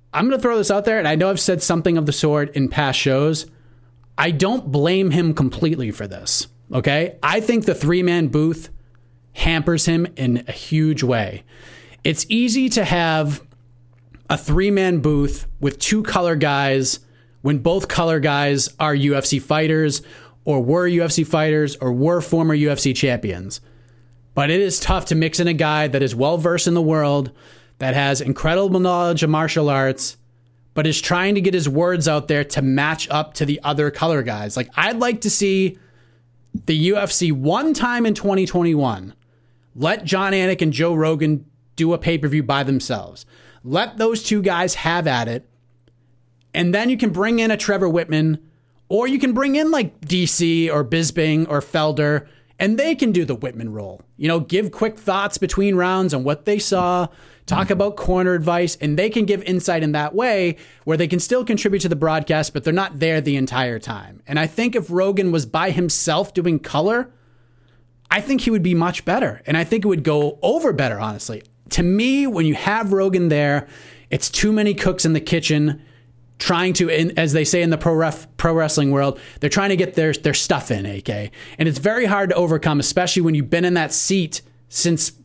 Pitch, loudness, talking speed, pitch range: 160 Hz, -19 LUFS, 195 wpm, 140-180 Hz